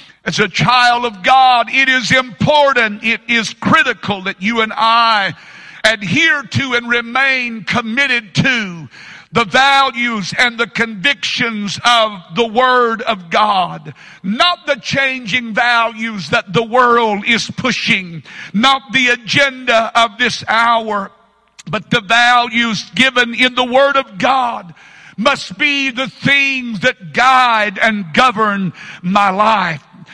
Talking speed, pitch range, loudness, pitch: 130 wpm, 210-255 Hz, -13 LUFS, 230 Hz